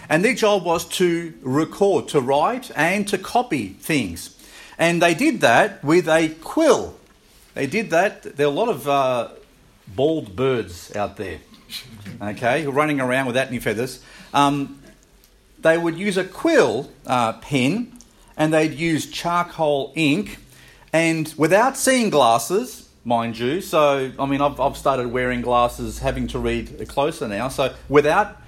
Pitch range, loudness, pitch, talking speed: 135-185 Hz, -20 LUFS, 155 Hz, 155 wpm